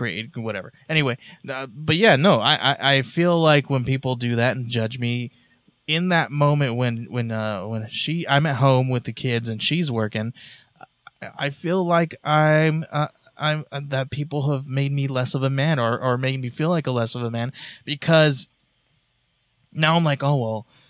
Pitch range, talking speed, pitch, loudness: 120-155 Hz, 195 wpm, 135 Hz, -21 LUFS